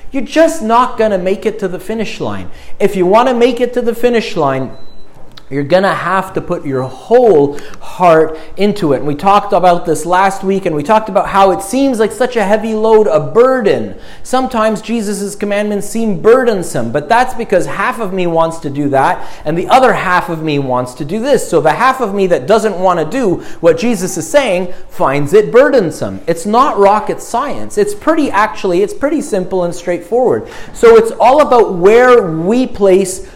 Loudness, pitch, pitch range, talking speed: -12 LUFS, 200 Hz, 170-235 Hz, 205 wpm